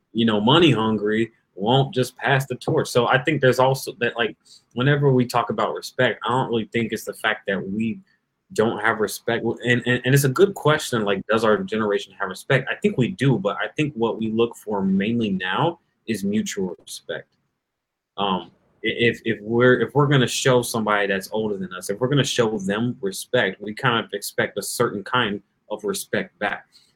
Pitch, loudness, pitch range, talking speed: 120 Hz, -22 LUFS, 110-135 Hz, 205 wpm